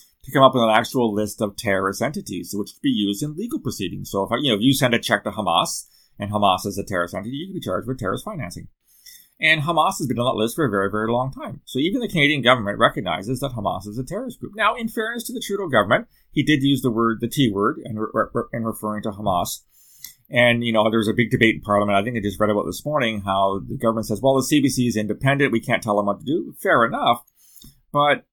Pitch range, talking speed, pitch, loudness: 105-140 Hz, 265 wpm, 115 Hz, -21 LUFS